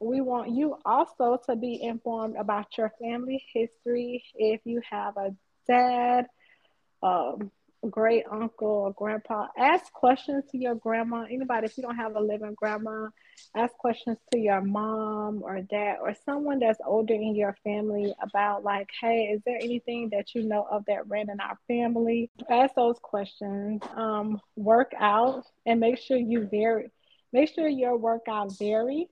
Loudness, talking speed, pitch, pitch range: -28 LUFS, 165 wpm, 230 Hz, 210-245 Hz